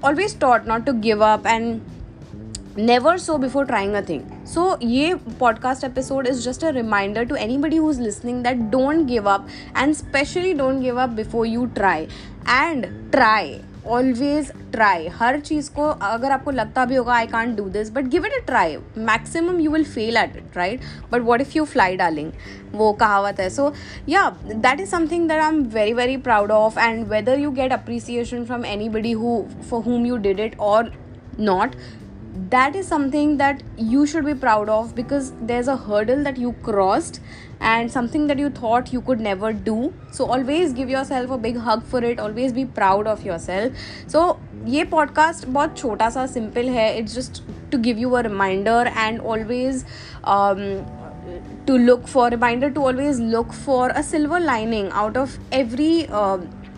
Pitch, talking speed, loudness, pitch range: 245 Hz, 185 wpm, -20 LUFS, 220-280 Hz